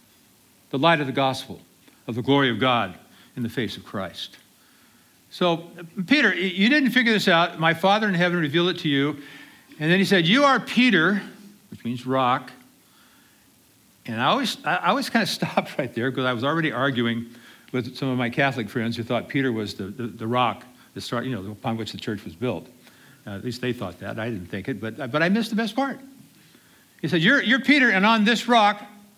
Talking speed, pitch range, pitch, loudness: 215 wpm, 120-195 Hz, 140 Hz, -22 LUFS